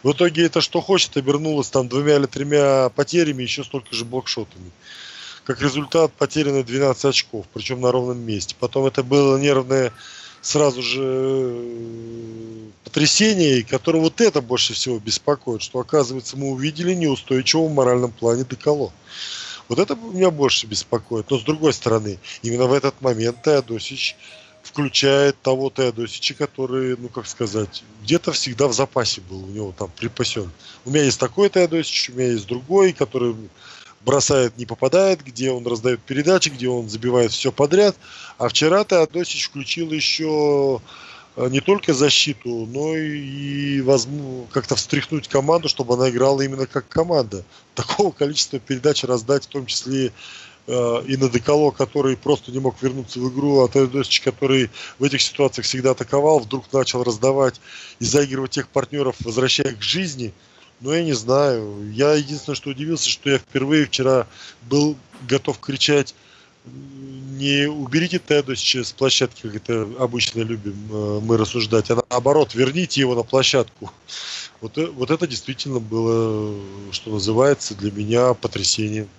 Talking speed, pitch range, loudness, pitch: 150 wpm, 120-145 Hz, -20 LUFS, 130 Hz